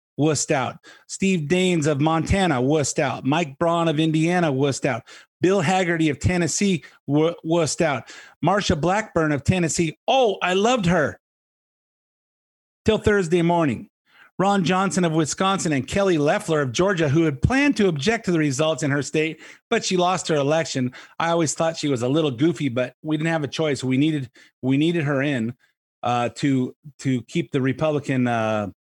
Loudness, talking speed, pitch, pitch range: -22 LUFS, 175 wpm, 160 Hz, 140-175 Hz